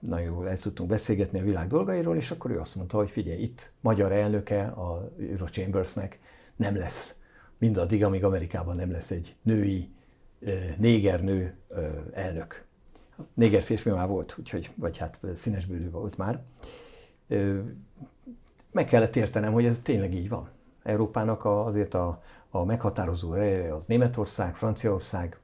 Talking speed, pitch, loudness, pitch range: 140 wpm, 100 Hz, -29 LUFS, 90-110 Hz